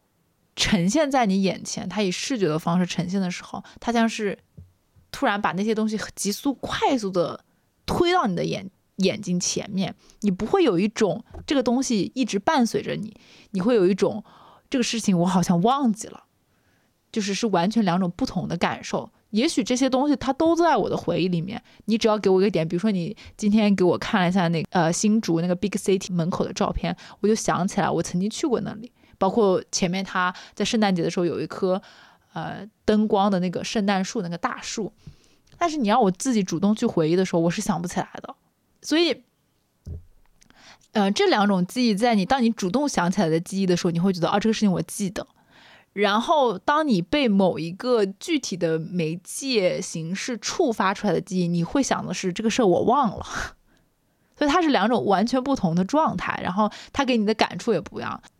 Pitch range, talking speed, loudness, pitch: 180-230 Hz, 305 characters per minute, -23 LUFS, 200 Hz